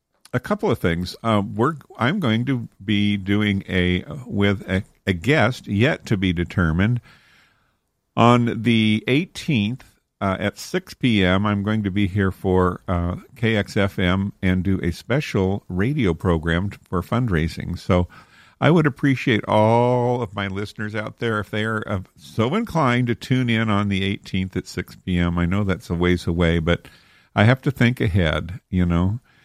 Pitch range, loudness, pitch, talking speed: 95-120 Hz, -21 LUFS, 100 Hz, 165 wpm